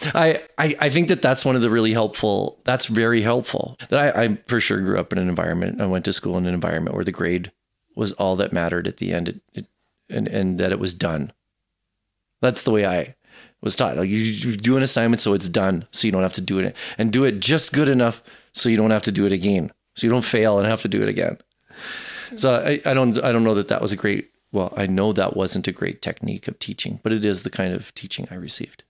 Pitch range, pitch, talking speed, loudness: 95-120 Hz, 105 Hz, 260 wpm, -21 LUFS